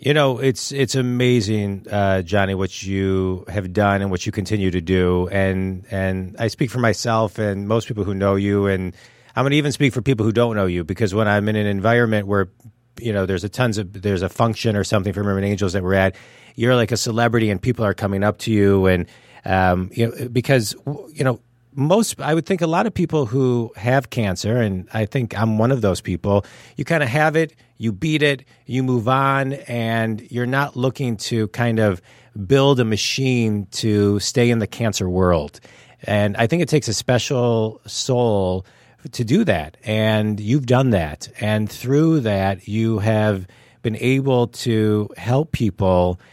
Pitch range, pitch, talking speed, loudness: 100-125 Hz, 110 Hz, 200 wpm, -20 LUFS